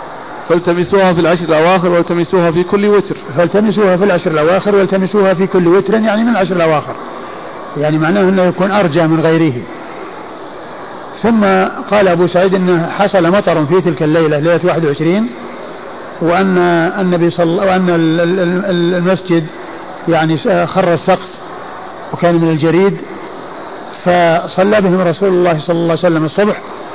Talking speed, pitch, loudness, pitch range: 130 wpm, 180 Hz, -12 LUFS, 170-190 Hz